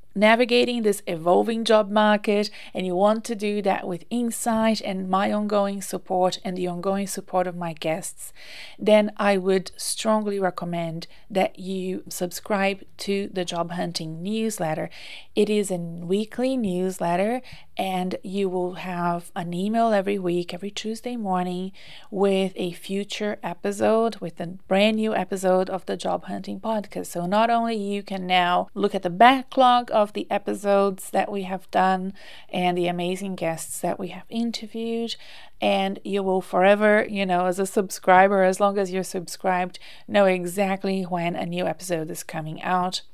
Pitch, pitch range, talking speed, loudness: 190 Hz, 180-210 Hz, 160 wpm, -24 LUFS